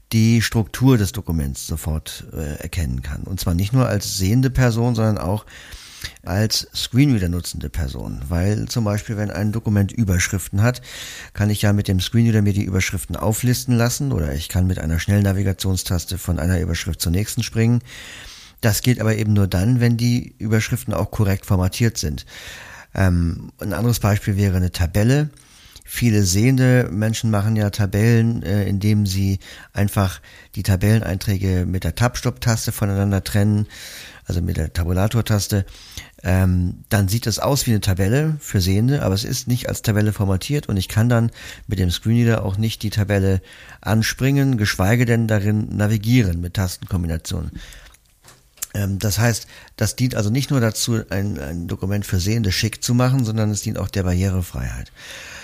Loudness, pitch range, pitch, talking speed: -20 LUFS, 95-115 Hz, 105 Hz, 165 wpm